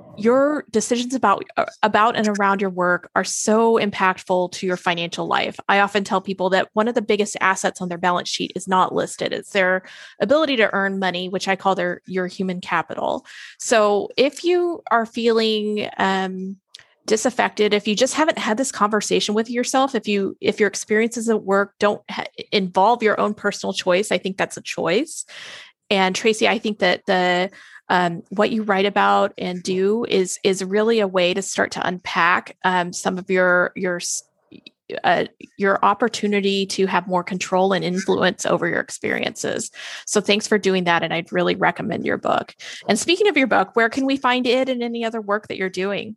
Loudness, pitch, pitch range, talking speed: -20 LUFS, 200 Hz, 185-225 Hz, 190 wpm